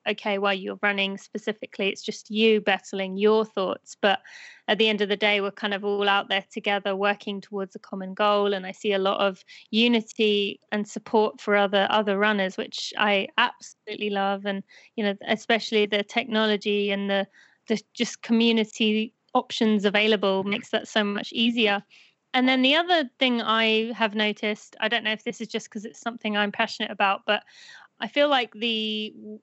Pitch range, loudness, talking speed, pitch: 200-225 Hz, -24 LUFS, 190 wpm, 215 Hz